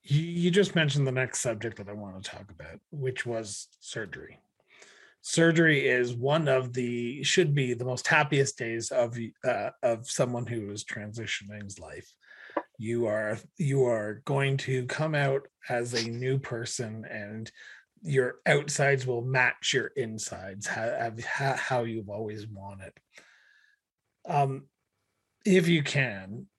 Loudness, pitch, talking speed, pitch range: -28 LUFS, 120 Hz, 140 wpm, 110-140 Hz